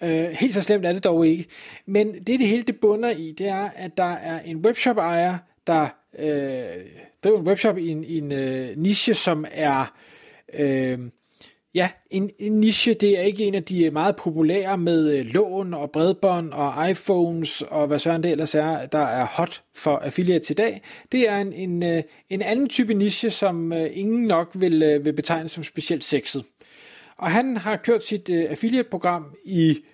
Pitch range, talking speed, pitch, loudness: 155-205 Hz, 180 wpm, 175 Hz, -22 LUFS